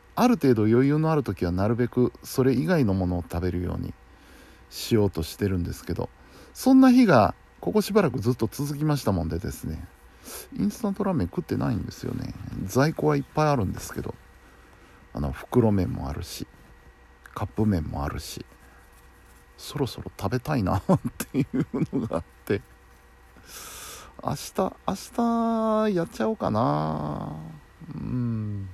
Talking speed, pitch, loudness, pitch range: 310 characters per minute, 110 Hz, -25 LUFS, 85-140 Hz